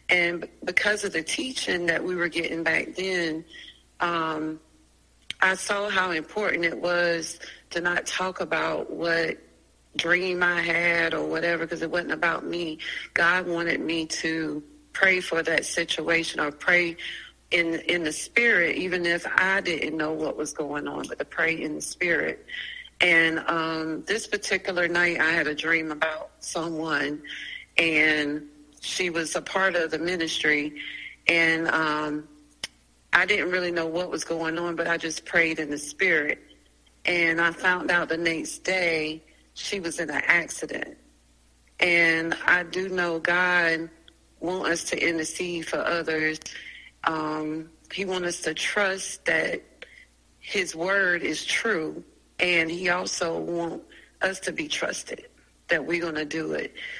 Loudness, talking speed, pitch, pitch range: -25 LUFS, 155 wpm, 165 Hz, 155-175 Hz